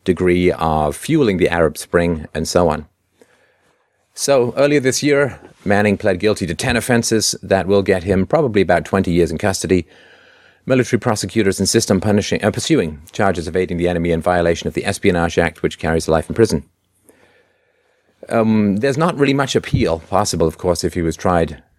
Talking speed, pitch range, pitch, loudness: 180 wpm, 85-110 Hz, 95 Hz, -17 LUFS